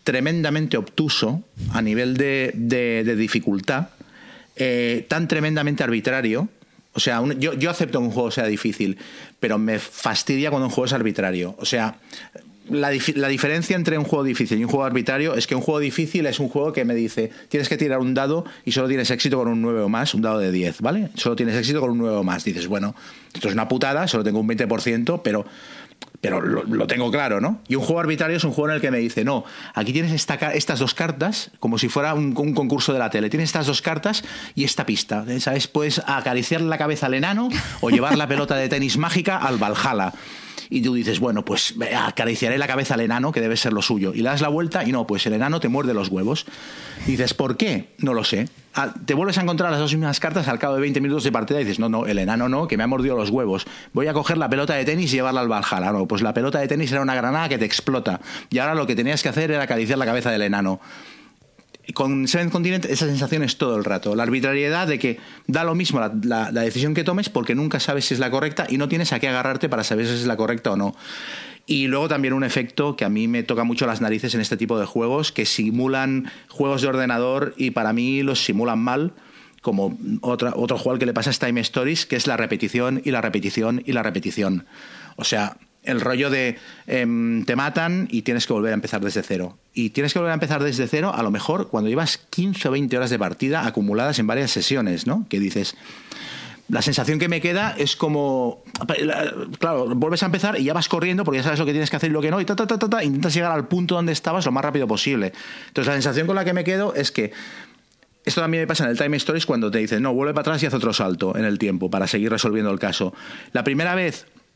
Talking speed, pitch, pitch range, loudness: 245 wpm, 135 Hz, 115-155 Hz, -22 LUFS